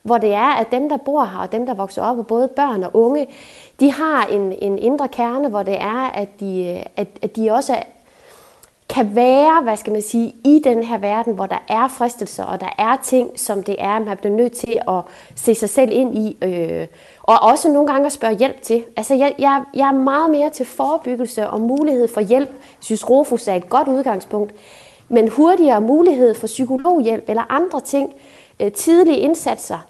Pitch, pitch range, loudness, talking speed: 245 Hz, 215-275 Hz, -17 LUFS, 205 wpm